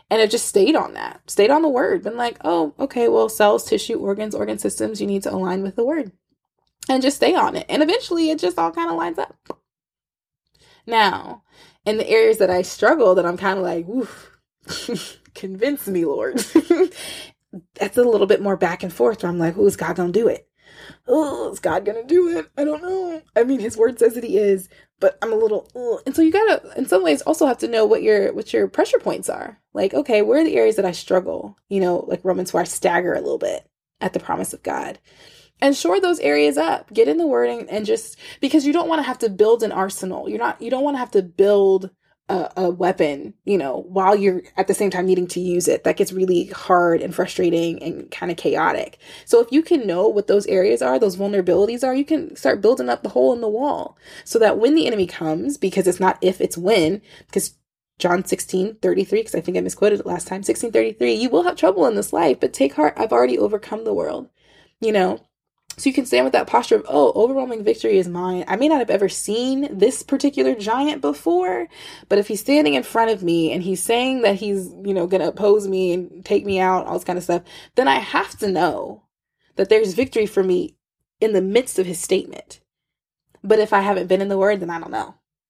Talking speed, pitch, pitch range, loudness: 230 wpm, 205 Hz, 180-280 Hz, -19 LUFS